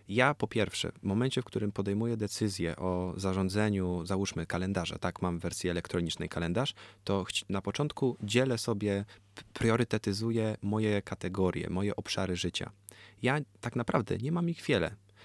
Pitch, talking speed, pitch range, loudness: 100 Hz, 150 wpm, 95-115 Hz, -32 LUFS